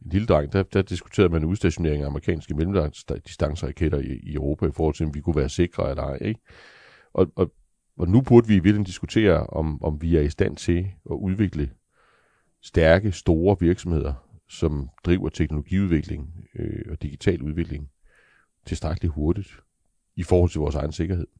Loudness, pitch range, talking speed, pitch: -24 LUFS, 75-95 Hz, 170 wpm, 85 Hz